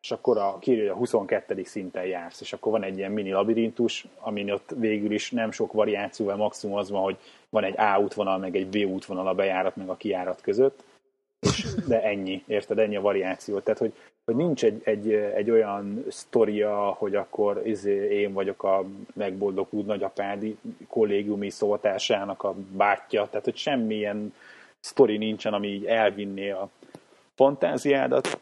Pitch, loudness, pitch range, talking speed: 105 Hz, -26 LUFS, 100-110 Hz, 160 wpm